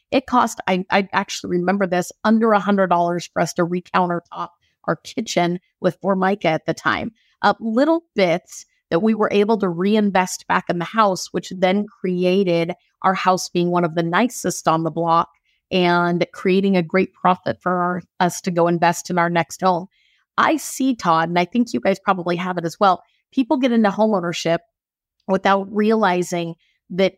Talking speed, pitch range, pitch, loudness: 180 wpm, 175-205 Hz, 185 Hz, -19 LUFS